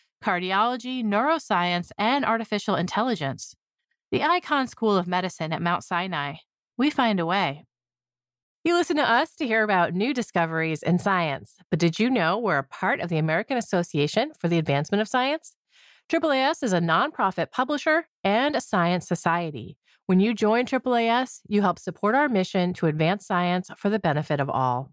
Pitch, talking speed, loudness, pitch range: 190 Hz, 170 wpm, -24 LUFS, 170-240 Hz